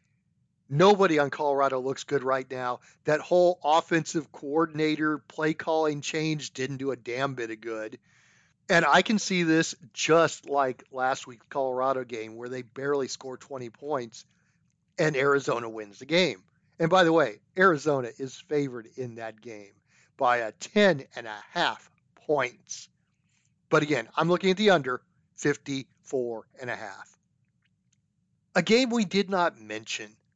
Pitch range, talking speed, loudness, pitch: 130-165 Hz, 150 wpm, -26 LUFS, 145 Hz